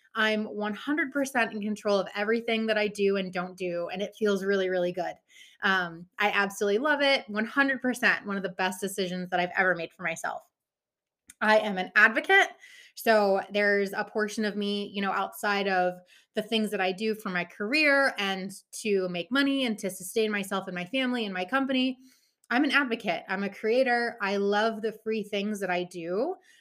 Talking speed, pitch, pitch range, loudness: 190 wpm, 205 Hz, 190-230 Hz, -27 LUFS